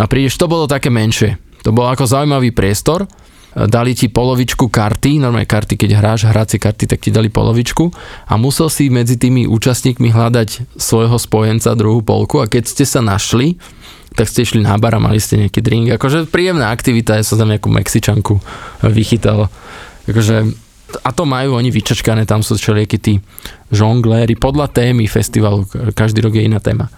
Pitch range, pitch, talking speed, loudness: 110-125 Hz, 115 Hz, 175 wpm, -13 LUFS